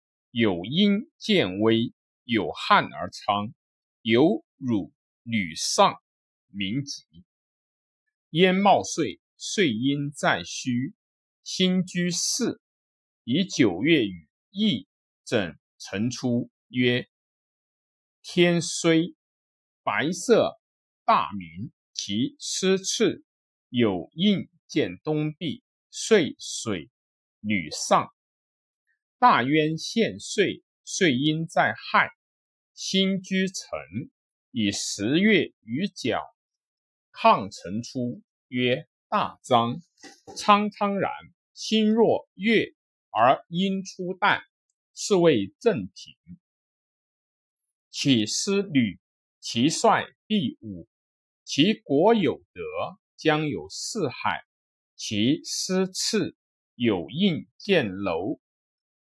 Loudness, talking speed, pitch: -25 LUFS, 110 characters per minute, 165 Hz